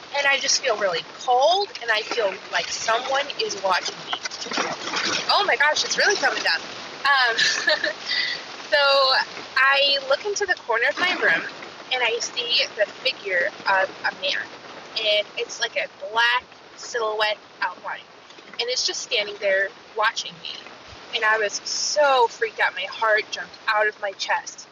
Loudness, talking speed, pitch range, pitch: -22 LUFS, 160 wpm, 230-370 Hz, 275 Hz